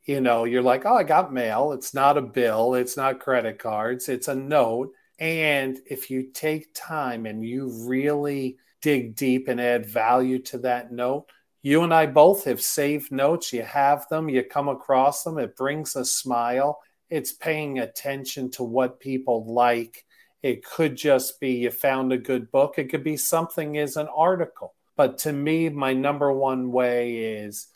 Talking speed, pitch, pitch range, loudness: 180 wpm, 135 Hz, 125-145 Hz, -24 LUFS